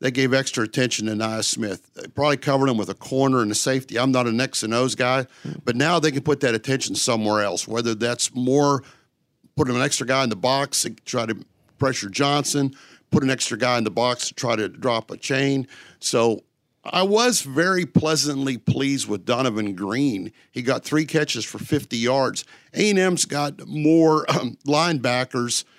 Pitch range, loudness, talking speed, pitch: 120-145 Hz, -22 LUFS, 195 wpm, 130 Hz